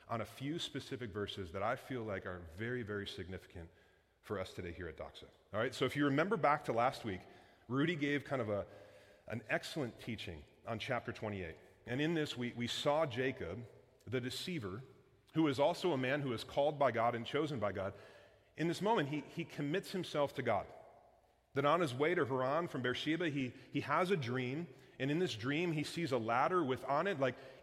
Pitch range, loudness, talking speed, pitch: 115-150 Hz, -38 LUFS, 210 wpm, 130 Hz